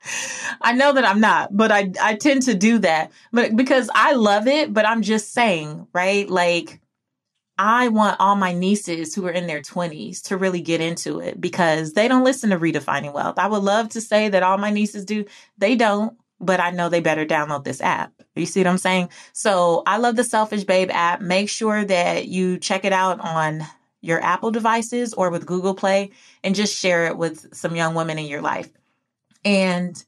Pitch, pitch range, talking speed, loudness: 195 Hz, 175-220 Hz, 205 wpm, -20 LUFS